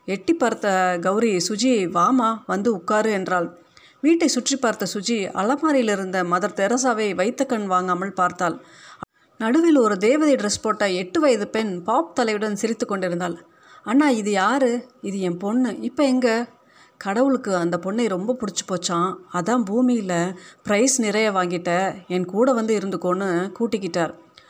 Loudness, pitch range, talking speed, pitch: -21 LUFS, 185-250 Hz, 135 wpm, 215 Hz